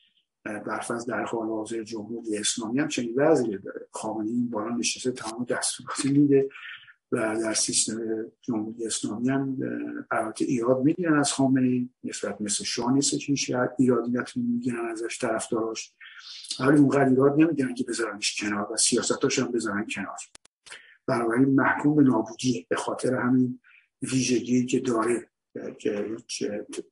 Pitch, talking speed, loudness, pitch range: 125 Hz, 135 wpm, -26 LUFS, 115-135 Hz